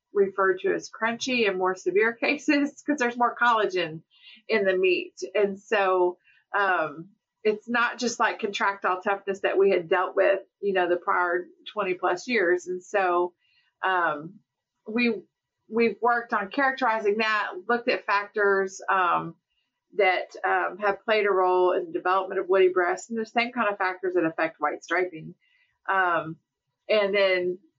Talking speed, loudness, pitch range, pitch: 160 wpm, -25 LUFS, 180-230 Hz, 200 Hz